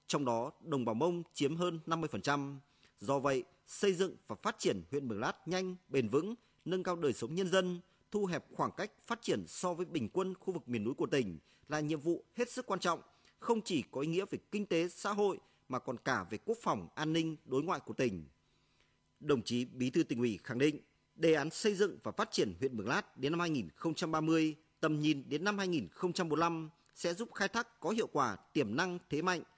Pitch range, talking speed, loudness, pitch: 140-185 Hz, 220 wpm, -36 LUFS, 165 Hz